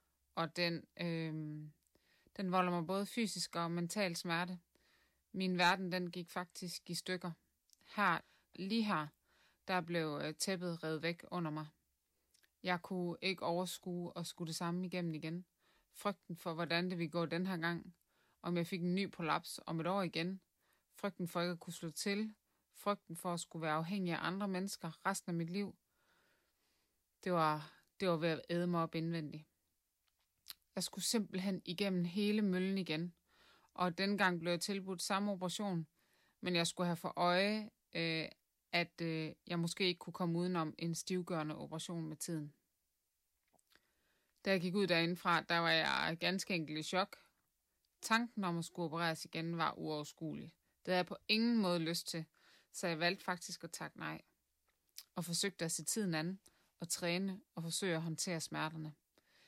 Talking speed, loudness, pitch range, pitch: 170 wpm, -39 LUFS, 165-185 Hz, 175 Hz